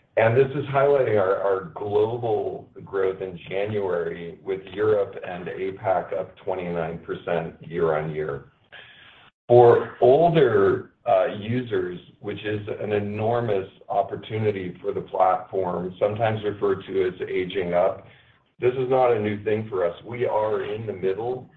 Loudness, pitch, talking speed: -24 LUFS, 140 Hz, 140 wpm